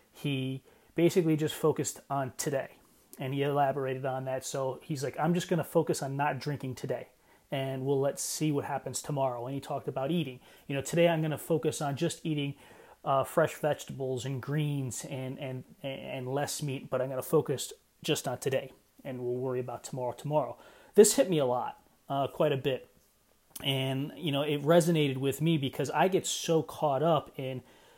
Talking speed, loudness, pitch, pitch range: 195 wpm, -31 LUFS, 140 Hz, 130-155 Hz